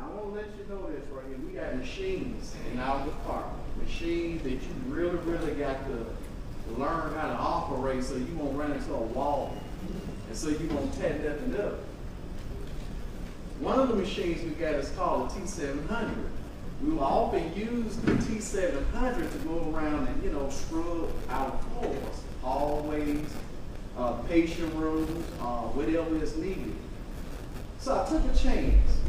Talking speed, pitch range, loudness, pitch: 170 wpm, 140-190 Hz, -32 LUFS, 160 Hz